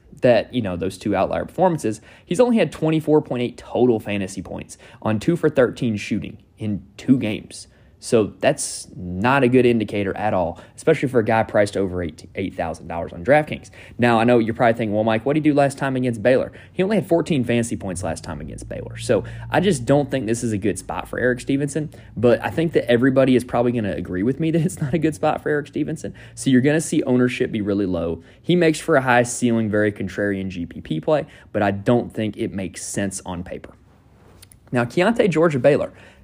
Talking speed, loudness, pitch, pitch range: 215 wpm, -20 LUFS, 115 Hz, 100-140 Hz